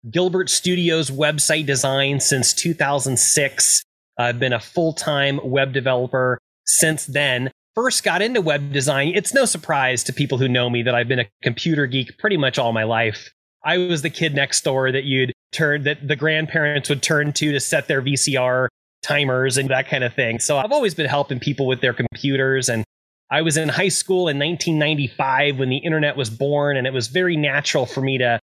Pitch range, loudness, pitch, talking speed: 130-155 Hz, -19 LUFS, 140 Hz, 195 wpm